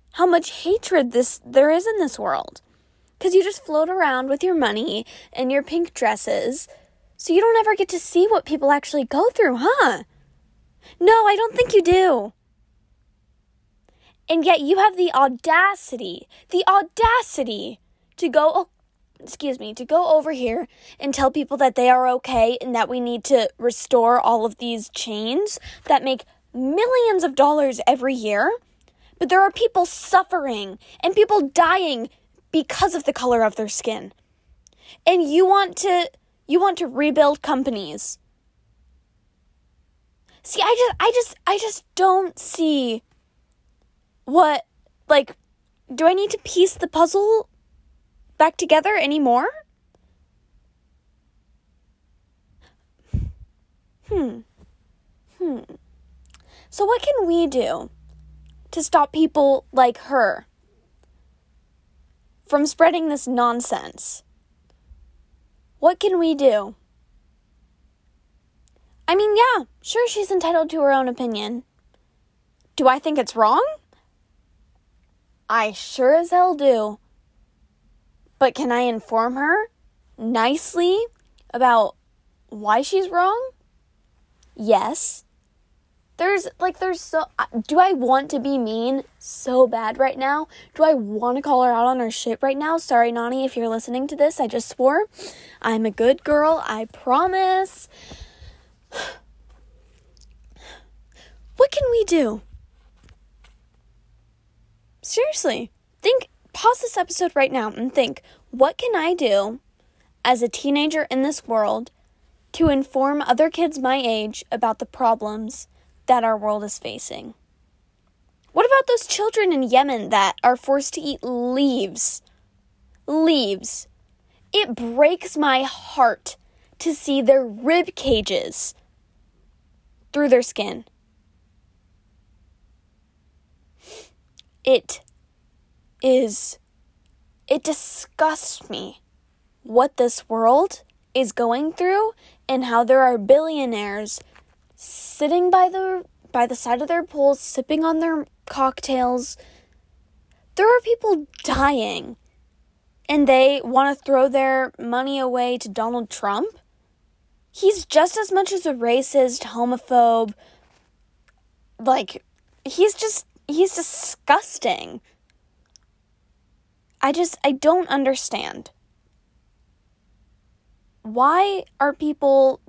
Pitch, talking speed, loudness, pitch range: 270 Hz, 120 wpm, -20 LUFS, 225-340 Hz